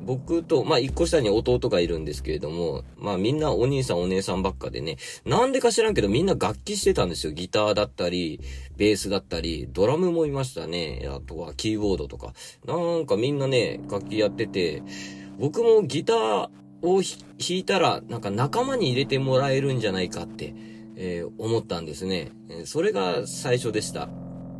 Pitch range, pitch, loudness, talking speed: 90-135 Hz, 110 Hz, -25 LUFS, 370 characters per minute